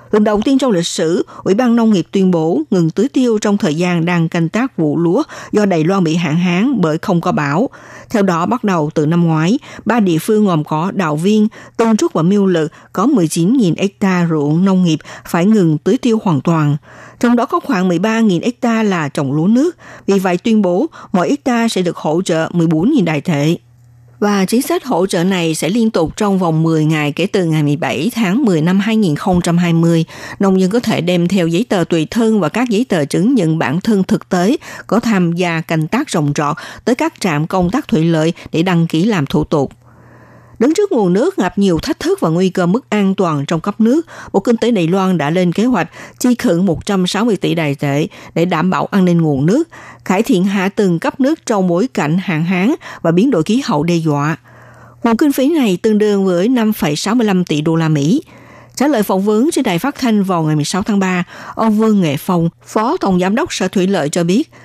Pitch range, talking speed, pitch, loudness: 165-220 Hz, 225 wpm, 185 Hz, -14 LUFS